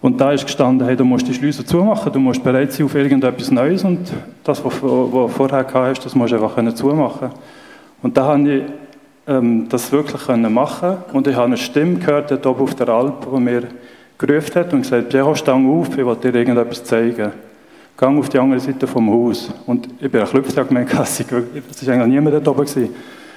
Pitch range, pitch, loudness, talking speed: 125-145 Hz, 135 Hz, -16 LUFS, 210 wpm